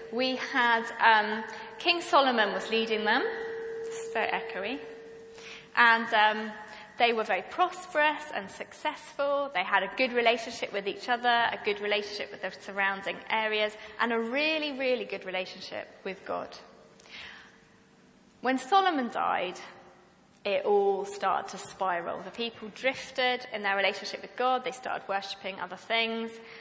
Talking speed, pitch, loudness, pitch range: 140 wpm, 225 Hz, -29 LUFS, 200-260 Hz